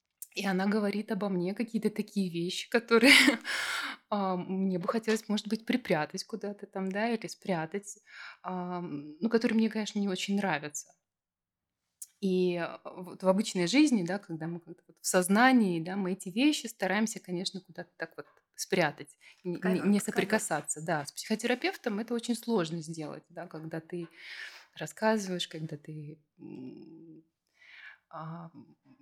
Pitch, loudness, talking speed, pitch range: 190 Hz, -30 LUFS, 125 wpm, 165-215 Hz